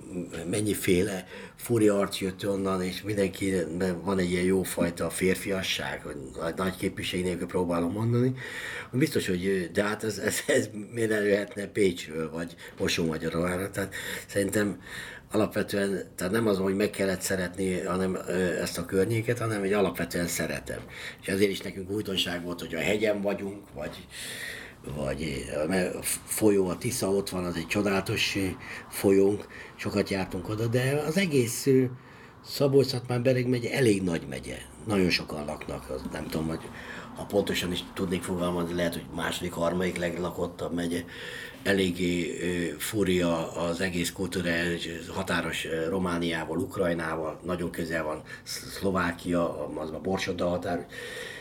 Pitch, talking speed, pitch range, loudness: 95 Hz, 135 wpm, 85-100 Hz, -29 LUFS